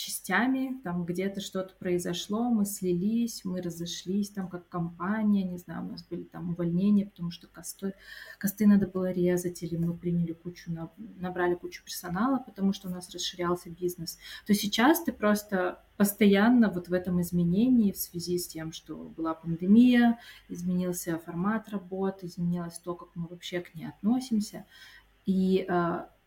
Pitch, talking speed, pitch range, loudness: 180 Hz, 155 wpm, 175-205 Hz, -29 LUFS